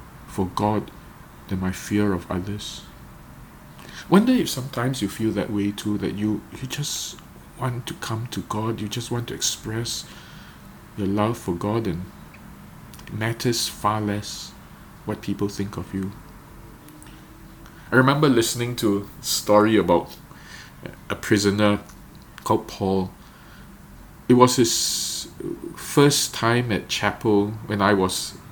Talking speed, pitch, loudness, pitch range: 135 wpm, 105 Hz, -23 LUFS, 100-120 Hz